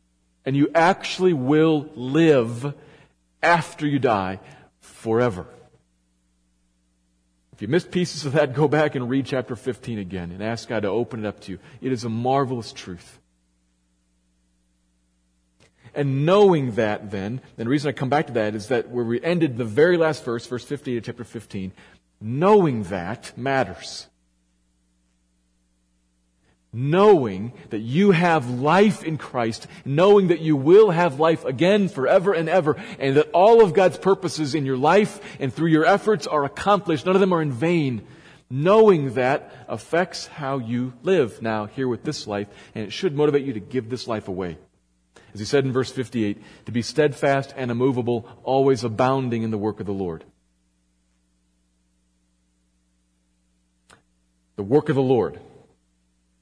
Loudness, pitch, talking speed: -21 LUFS, 125 Hz, 155 wpm